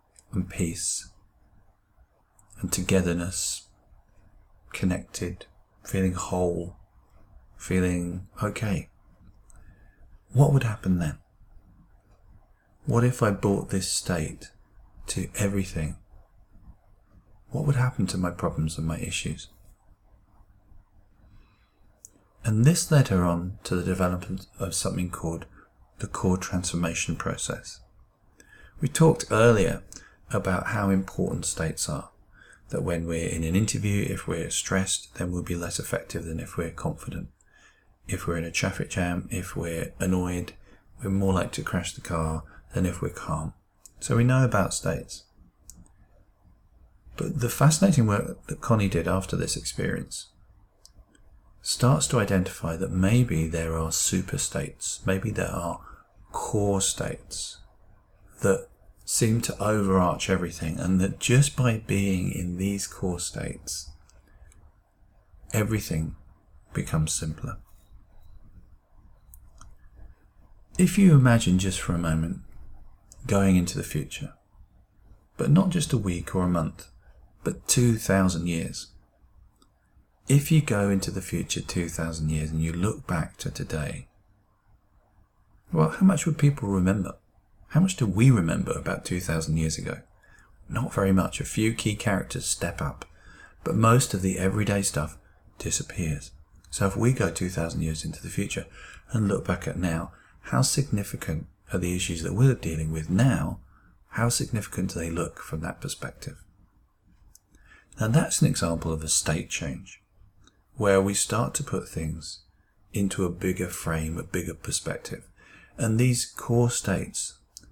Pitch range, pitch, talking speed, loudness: 85-105 Hz, 95 Hz, 135 wpm, -26 LUFS